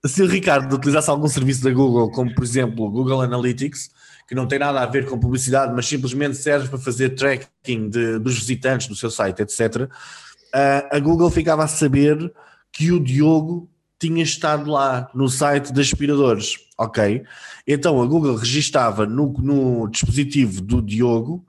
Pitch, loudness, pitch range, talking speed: 135 Hz, -19 LUFS, 125-145 Hz, 170 wpm